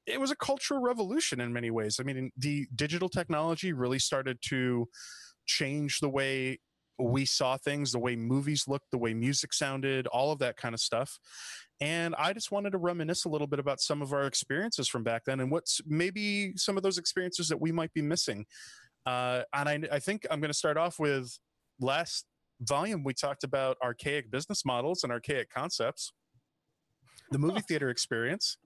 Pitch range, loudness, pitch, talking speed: 130-165 Hz, -32 LUFS, 145 Hz, 190 wpm